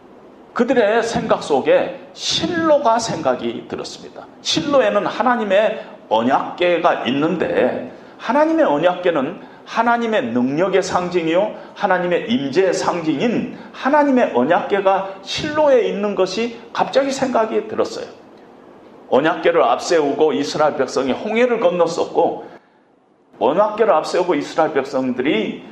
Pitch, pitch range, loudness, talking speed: 230 Hz, 185-265 Hz, -18 LUFS, 290 characters per minute